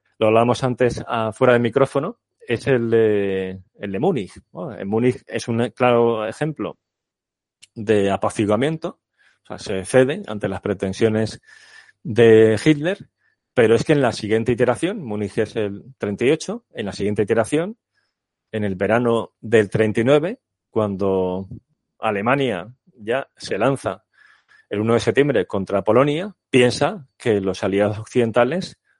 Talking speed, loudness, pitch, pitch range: 135 wpm, -20 LUFS, 115 Hz, 105-135 Hz